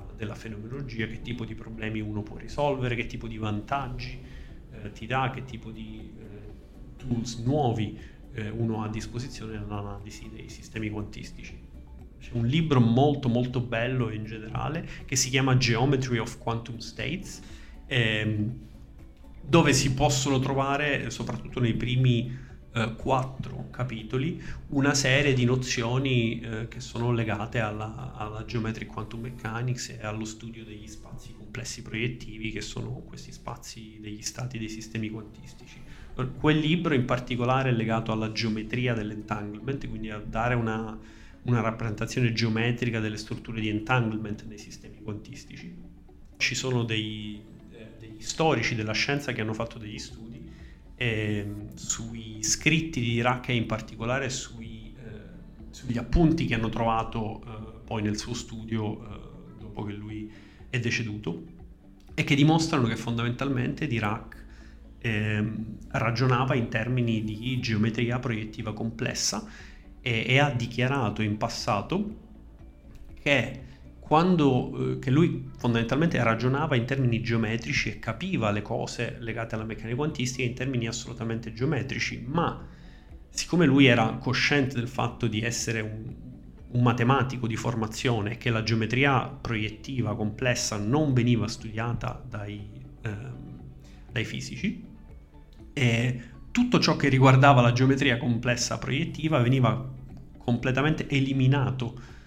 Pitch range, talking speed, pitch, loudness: 110-125 Hz, 135 wpm, 115 Hz, -27 LUFS